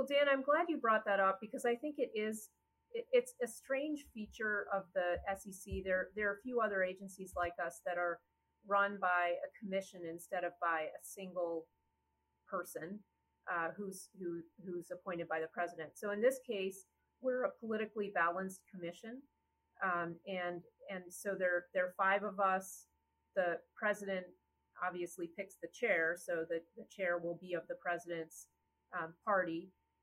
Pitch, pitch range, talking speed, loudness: 185 Hz, 170-210 Hz, 170 wpm, -39 LUFS